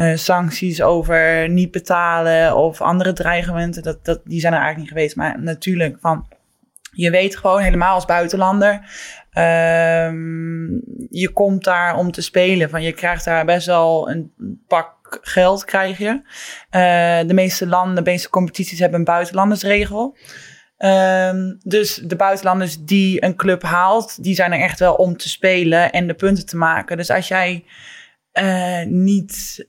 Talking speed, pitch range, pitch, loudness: 160 wpm, 170-190 Hz, 180 Hz, -17 LUFS